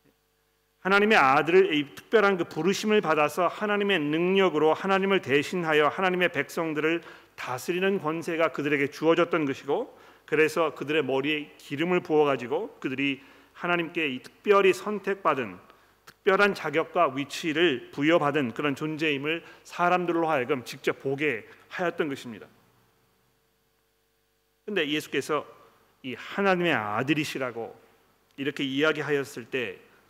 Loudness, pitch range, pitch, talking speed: -26 LUFS, 145-185 Hz, 160 Hz, 315 characters per minute